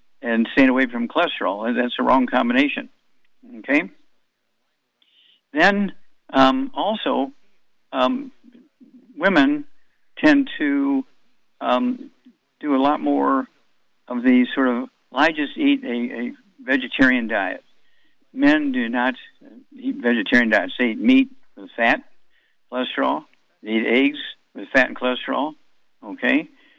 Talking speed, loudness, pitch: 120 wpm, -20 LUFS, 255 Hz